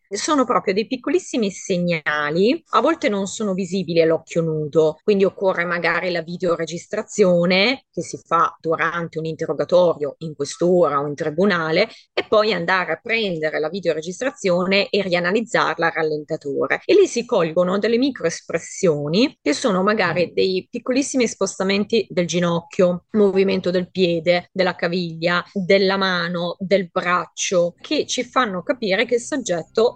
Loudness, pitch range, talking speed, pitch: -20 LUFS, 170-215 Hz, 140 wpm, 180 Hz